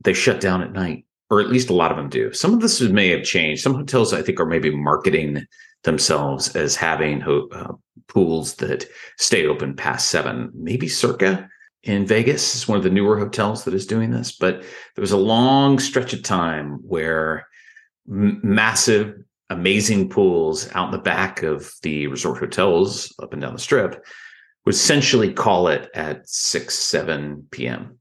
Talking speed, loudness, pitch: 180 wpm, -19 LUFS, 105 Hz